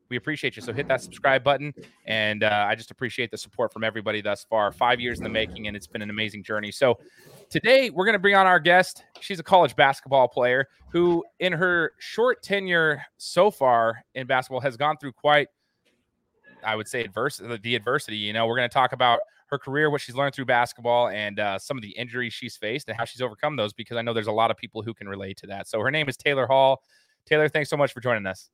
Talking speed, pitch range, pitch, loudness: 245 wpm, 110-150 Hz, 125 Hz, -24 LUFS